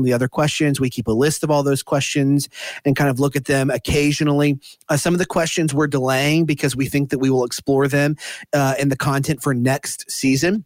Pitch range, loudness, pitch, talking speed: 135-150 Hz, -19 LUFS, 140 Hz, 225 wpm